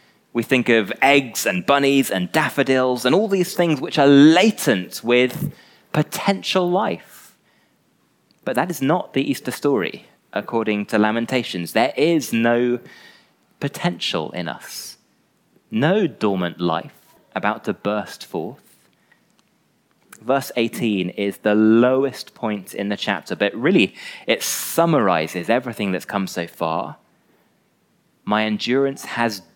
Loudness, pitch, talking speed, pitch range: -20 LUFS, 125 Hz, 125 wpm, 105-140 Hz